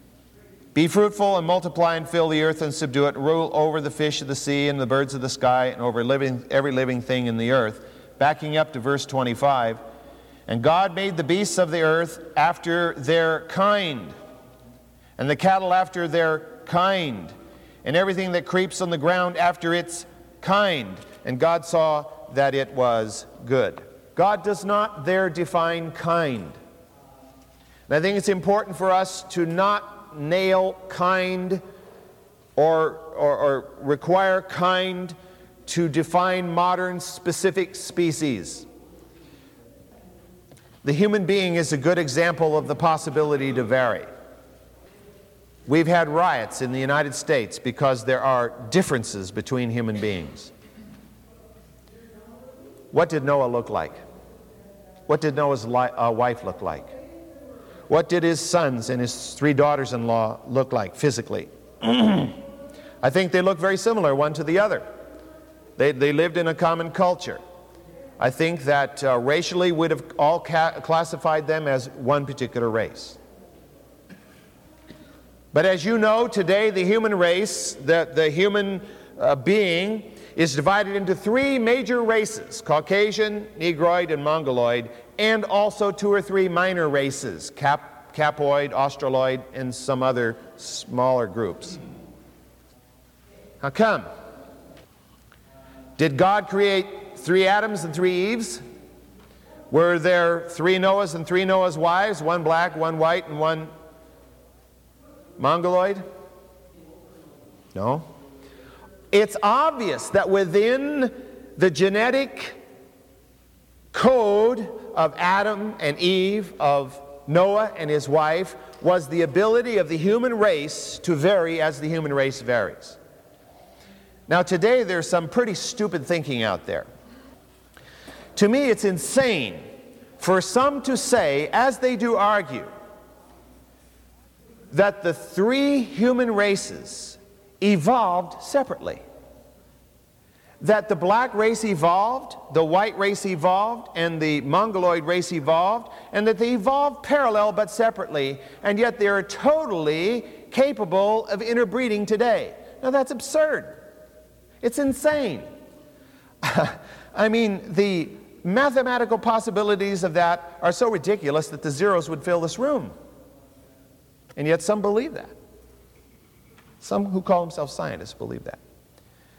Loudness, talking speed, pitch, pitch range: -22 LUFS, 130 wpm, 175 Hz, 145-200 Hz